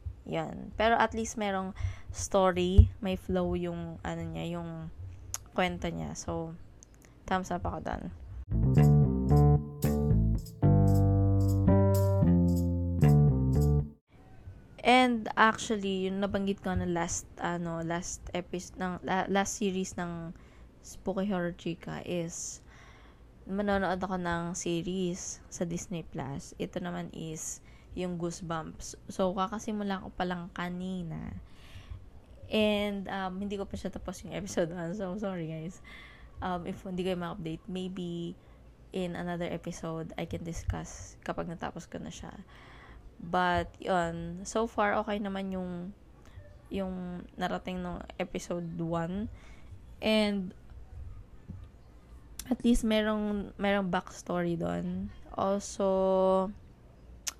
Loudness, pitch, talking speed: -31 LUFS, 175 Hz, 110 wpm